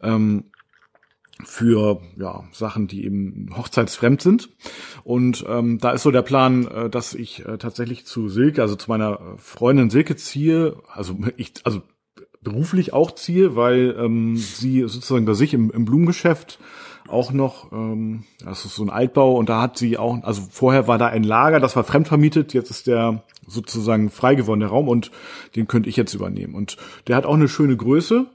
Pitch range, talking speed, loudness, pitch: 110-135 Hz, 185 wpm, -19 LUFS, 120 Hz